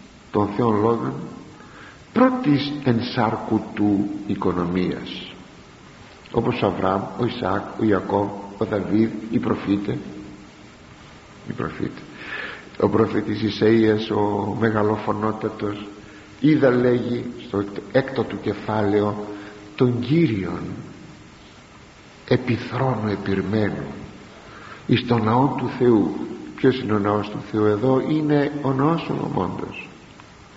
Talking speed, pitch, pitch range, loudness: 100 wpm, 110 Hz, 100-125 Hz, -22 LUFS